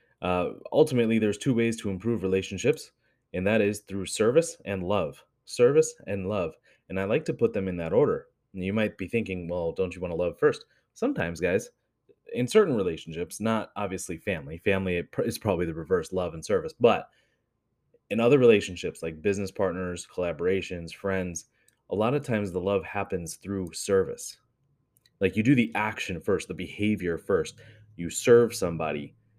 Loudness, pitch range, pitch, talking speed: -27 LUFS, 90-120 Hz, 100 Hz, 175 wpm